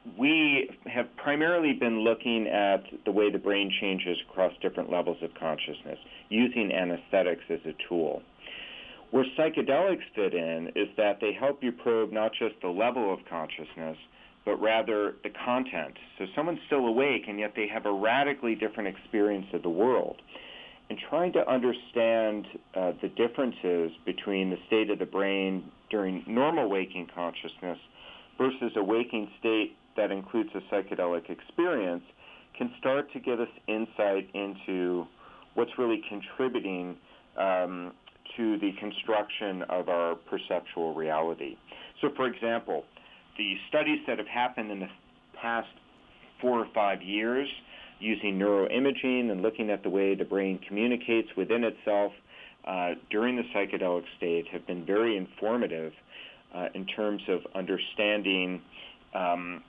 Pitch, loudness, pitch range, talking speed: 105 Hz, -30 LUFS, 95-120 Hz, 145 wpm